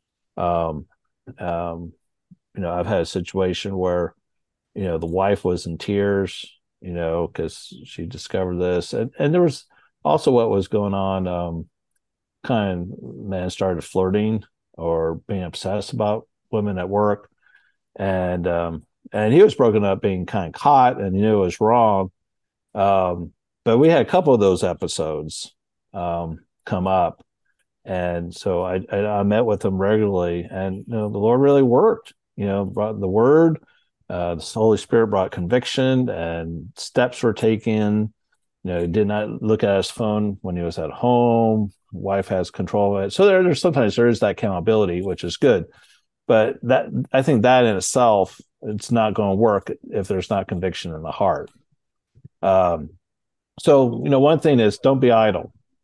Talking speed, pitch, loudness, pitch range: 175 wpm, 100 Hz, -20 LUFS, 90-110 Hz